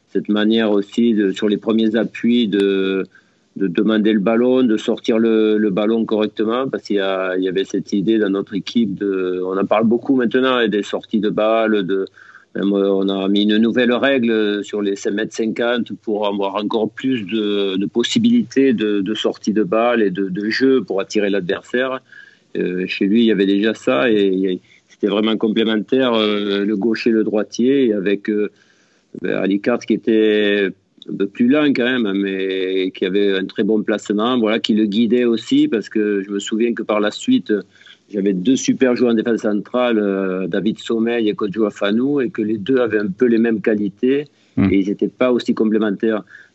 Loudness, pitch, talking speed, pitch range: -18 LUFS, 110 Hz, 200 wpm, 100-115 Hz